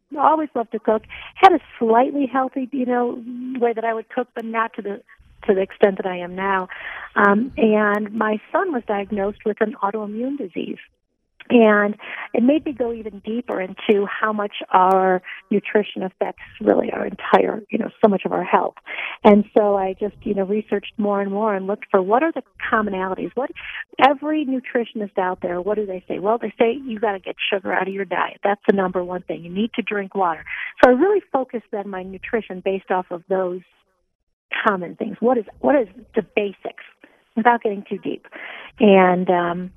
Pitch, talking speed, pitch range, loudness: 215 Hz, 200 wpm, 195-240 Hz, -20 LUFS